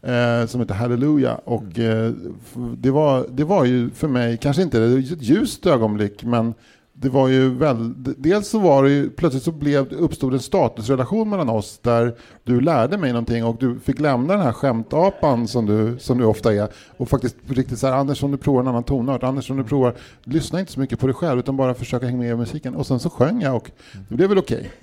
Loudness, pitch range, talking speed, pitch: -20 LUFS, 120-140 Hz, 235 wpm, 130 Hz